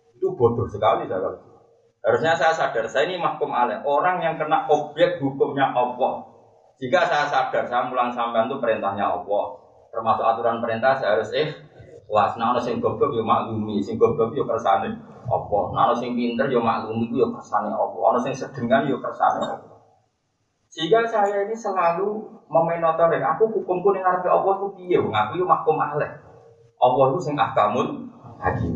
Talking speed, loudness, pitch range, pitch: 165 wpm, -22 LUFS, 120-195 Hz, 155 Hz